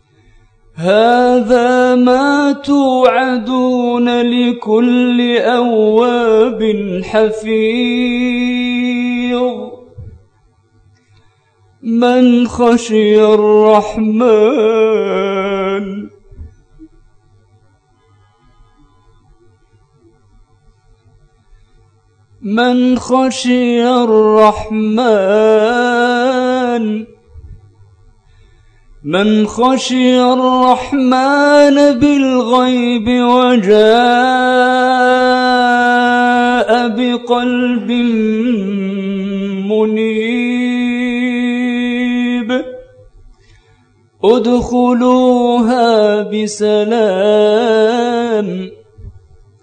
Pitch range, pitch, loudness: 145-245 Hz, 225 Hz, -12 LUFS